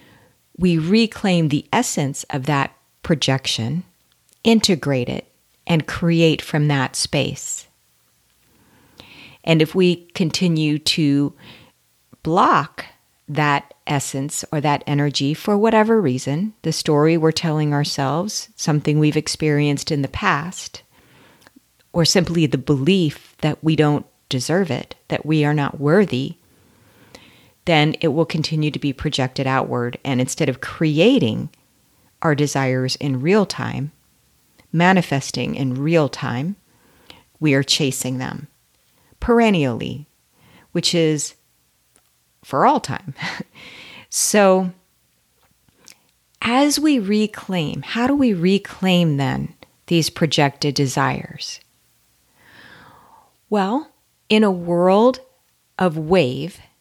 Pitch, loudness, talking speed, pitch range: 155 Hz, -19 LUFS, 110 wpm, 135-180 Hz